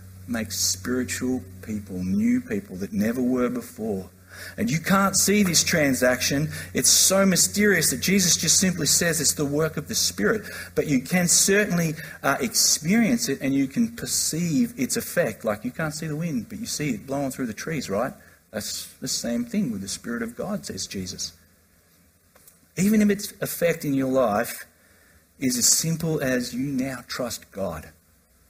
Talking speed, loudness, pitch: 175 wpm, -23 LUFS, 150 Hz